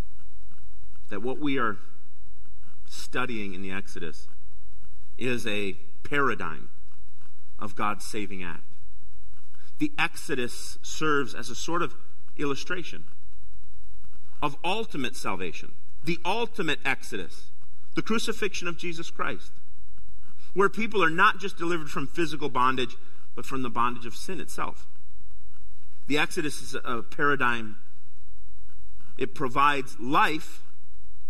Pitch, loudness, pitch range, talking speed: 95 Hz, -29 LUFS, 90-130 Hz, 110 wpm